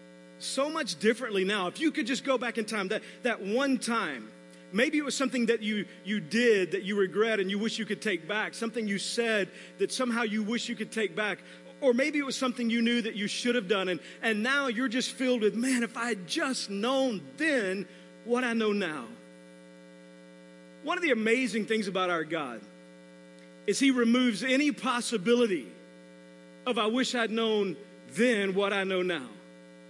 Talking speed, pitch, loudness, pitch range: 195 wpm, 220 Hz, -29 LUFS, 180-245 Hz